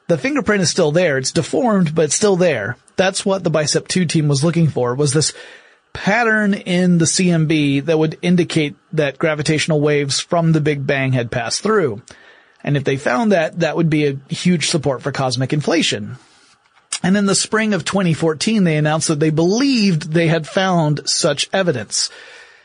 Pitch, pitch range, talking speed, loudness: 165 Hz, 150-190 Hz, 185 wpm, -17 LUFS